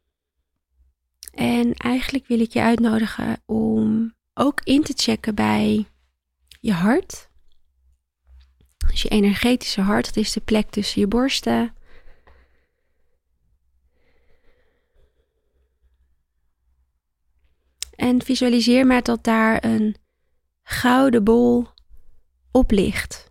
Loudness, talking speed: -20 LUFS, 90 wpm